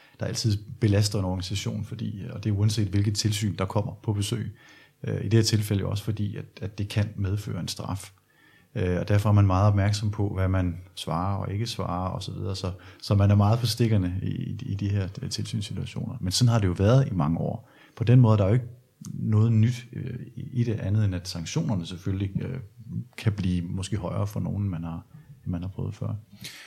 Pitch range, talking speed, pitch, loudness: 95-115 Hz, 230 wpm, 105 Hz, -26 LUFS